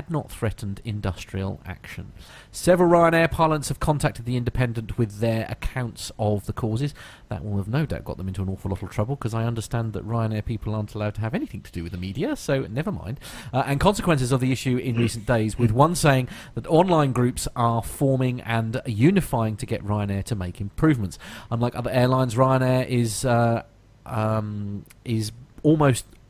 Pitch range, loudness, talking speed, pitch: 105-130 Hz, -24 LUFS, 190 wpm, 115 Hz